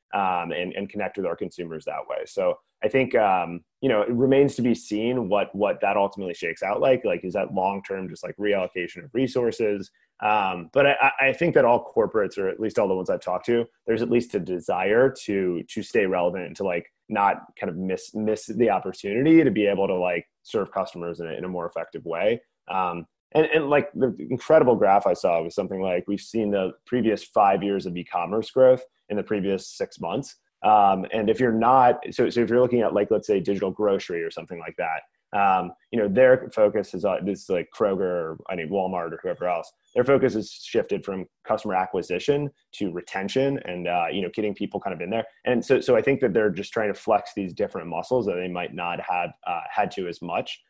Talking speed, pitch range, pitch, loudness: 230 wpm, 95-135 Hz, 110 Hz, -24 LUFS